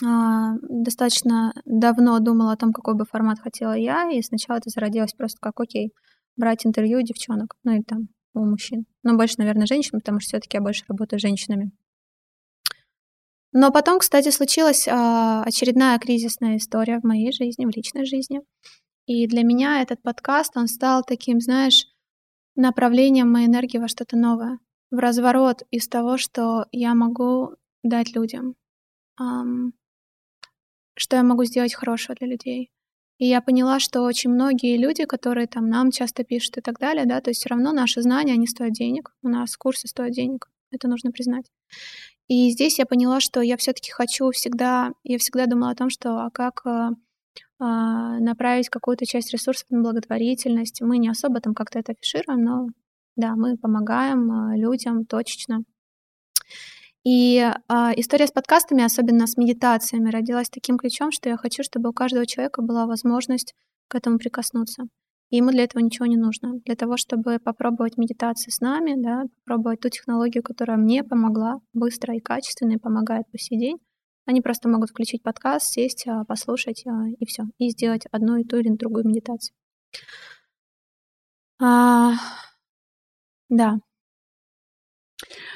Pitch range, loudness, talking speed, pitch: 230-250 Hz, -21 LUFS, 155 wpm, 240 Hz